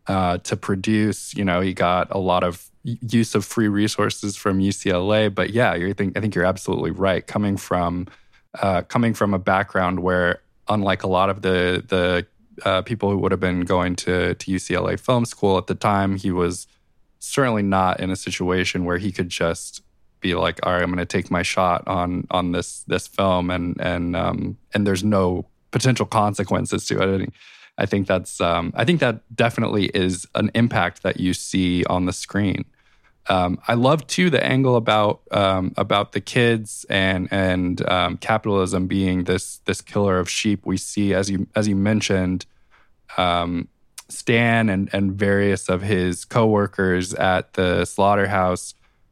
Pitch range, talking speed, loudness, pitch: 90-105 Hz, 175 wpm, -21 LUFS, 95 Hz